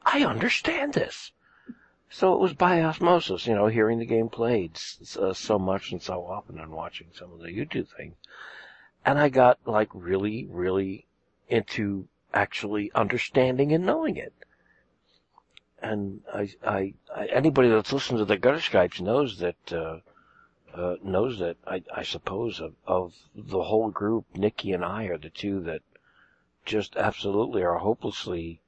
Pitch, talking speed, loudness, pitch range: 105 Hz, 155 wpm, -26 LUFS, 95-125 Hz